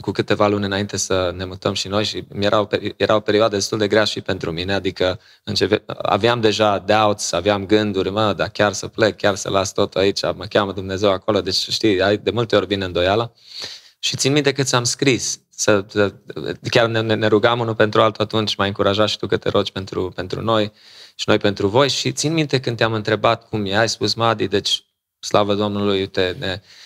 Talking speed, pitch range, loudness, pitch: 205 wpm, 100-115 Hz, -19 LUFS, 105 Hz